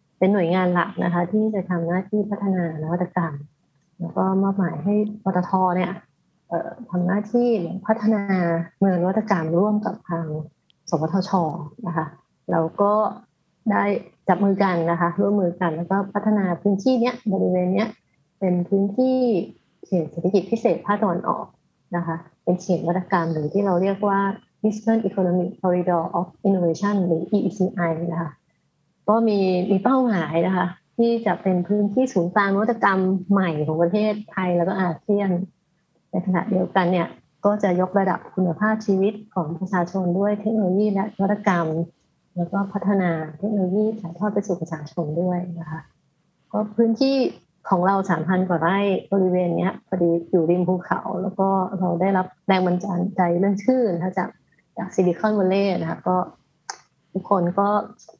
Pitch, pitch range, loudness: 185 Hz, 175-200 Hz, -22 LUFS